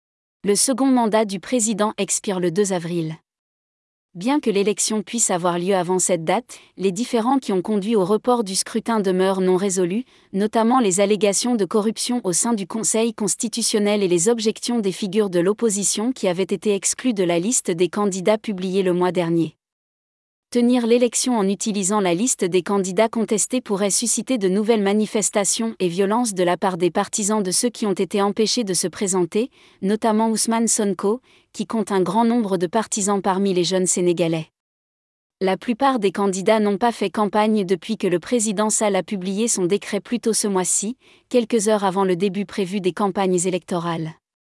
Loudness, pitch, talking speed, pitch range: -20 LUFS, 205 Hz, 180 wpm, 190-225 Hz